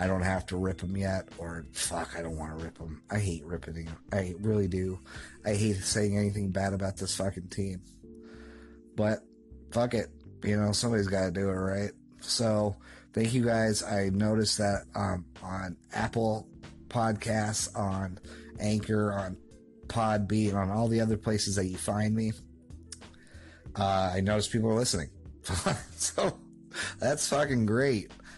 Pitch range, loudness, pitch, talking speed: 85-110 Hz, -31 LUFS, 100 Hz, 160 wpm